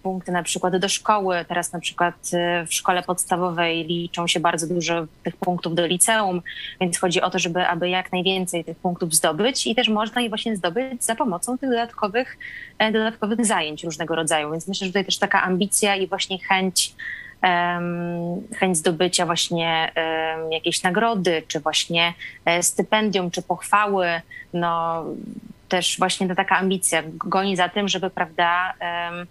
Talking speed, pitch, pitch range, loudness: 155 wpm, 180 Hz, 170-200 Hz, -22 LUFS